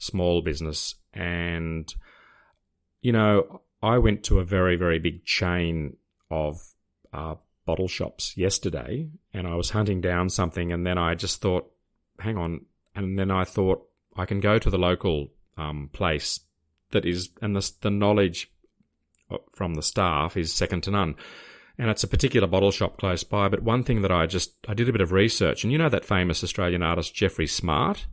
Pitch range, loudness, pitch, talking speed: 85-100 Hz, -25 LUFS, 90 Hz, 180 wpm